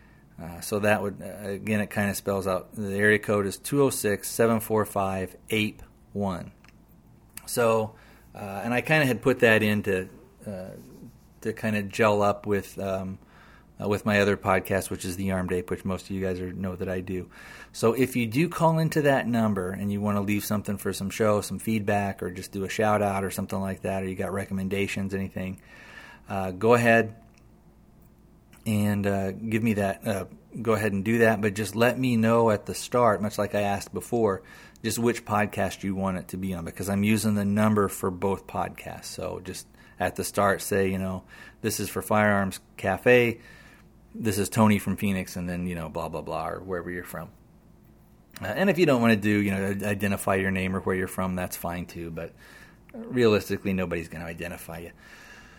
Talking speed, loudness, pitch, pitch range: 205 wpm, -26 LUFS, 100 Hz, 95-110 Hz